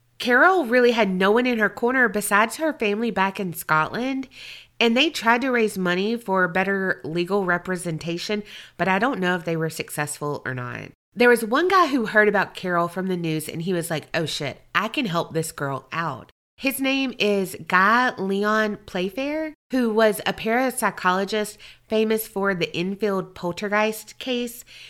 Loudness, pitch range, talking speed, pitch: -22 LUFS, 175-235 Hz, 175 wpm, 200 Hz